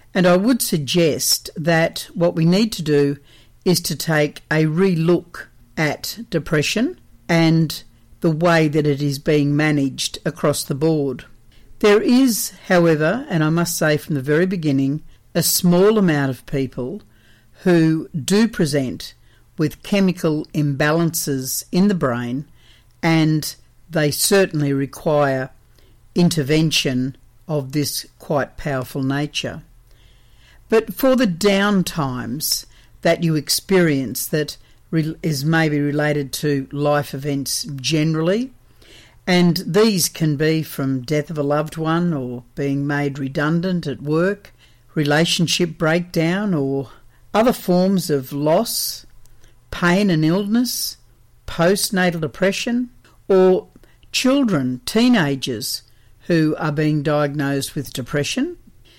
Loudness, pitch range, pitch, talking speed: -19 LUFS, 135-175 Hz, 155 Hz, 115 wpm